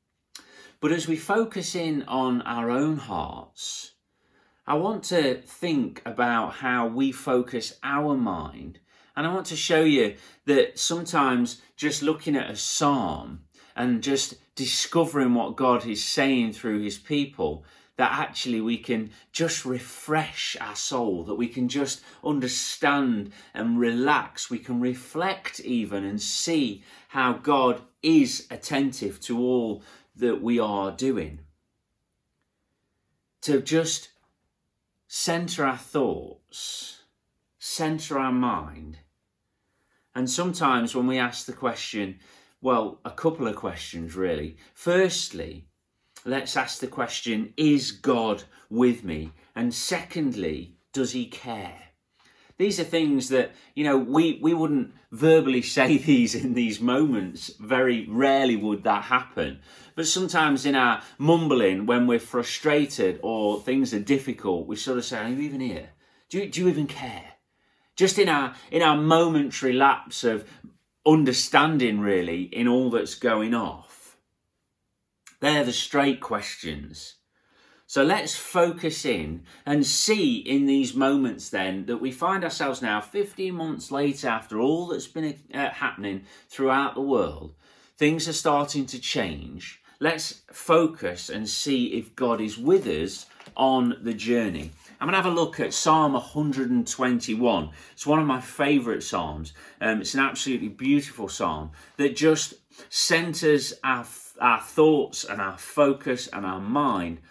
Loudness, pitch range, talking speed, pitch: -25 LUFS, 115-155 Hz, 140 wpm, 130 Hz